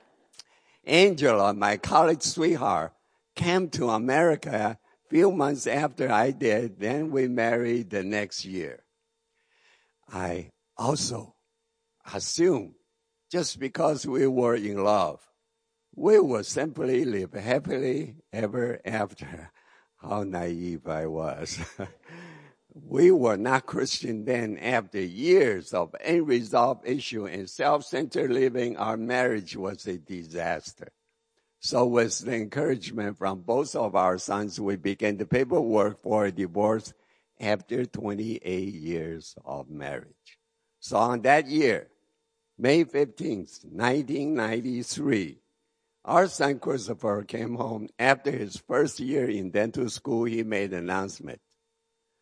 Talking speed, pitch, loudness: 115 wpm, 120 Hz, -26 LUFS